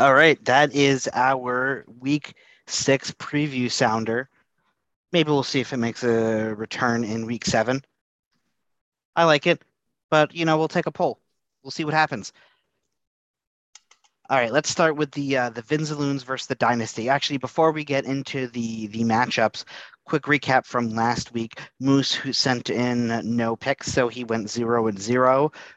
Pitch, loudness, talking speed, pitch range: 130 Hz, -23 LUFS, 165 wpm, 115-145 Hz